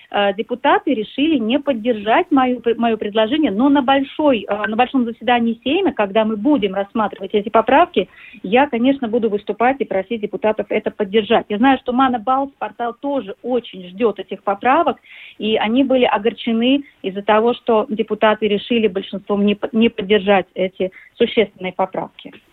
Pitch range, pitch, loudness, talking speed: 210-255 Hz, 230 Hz, -18 LUFS, 145 wpm